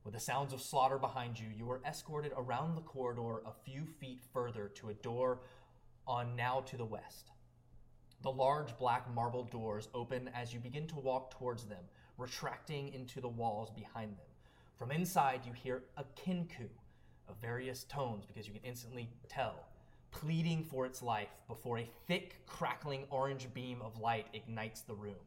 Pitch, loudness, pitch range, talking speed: 125 Hz, -41 LUFS, 115-135 Hz, 175 wpm